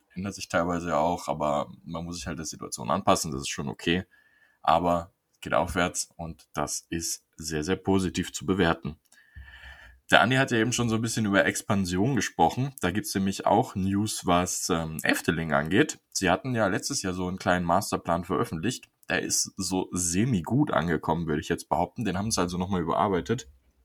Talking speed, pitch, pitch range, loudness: 190 wpm, 90 Hz, 85-100 Hz, -27 LUFS